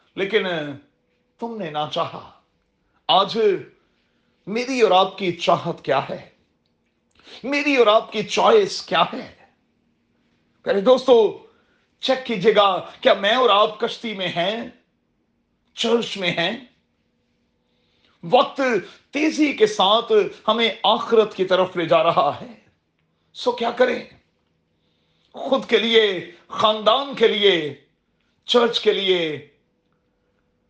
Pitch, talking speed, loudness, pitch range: 215 Hz, 115 wpm, -19 LUFS, 170-250 Hz